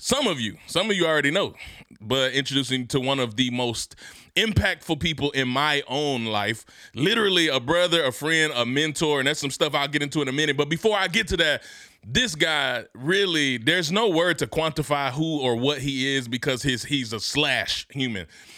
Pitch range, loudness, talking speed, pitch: 130-155 Hz, -23 LUFS, 205 wpm, 145 Hz